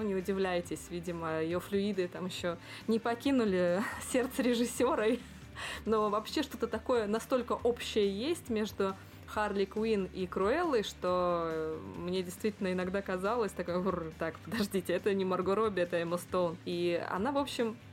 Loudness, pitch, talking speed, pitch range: -33 LUFS, 195 Hz, 140 wpm, 180-220 Hz